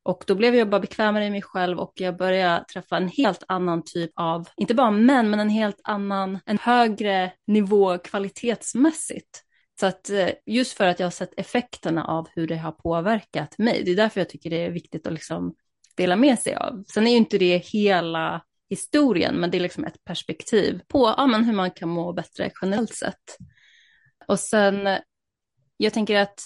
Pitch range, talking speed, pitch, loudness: 180-220 Hz, 195 wpm, 195 Hz, -23 LUFS